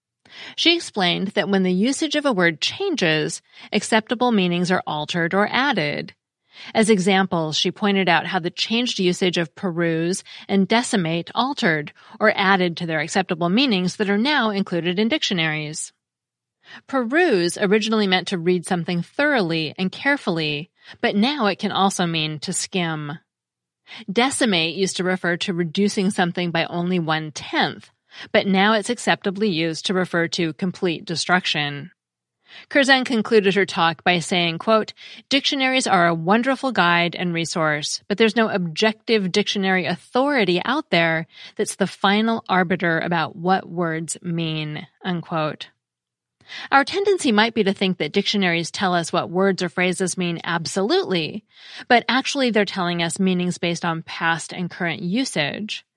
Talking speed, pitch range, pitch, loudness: 150 wpm, 170-215 Hz, 185 Hz, -20 LUFS